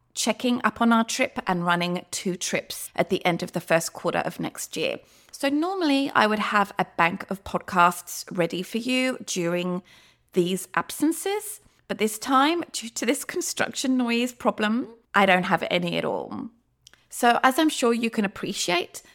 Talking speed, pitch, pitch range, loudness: 175 wpm, 215 Hz, 180-255 Hz, -24 LUFS